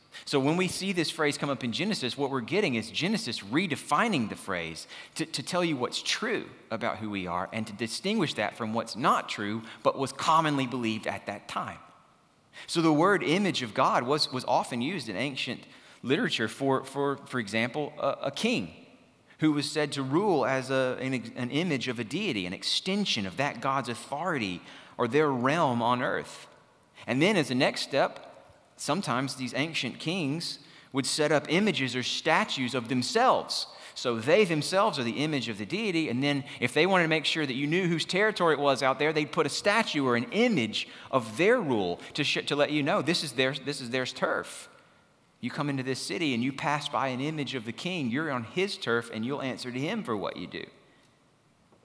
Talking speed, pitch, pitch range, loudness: 210 wpm, 140 Hz, 125-155 Hz, -28 LUFS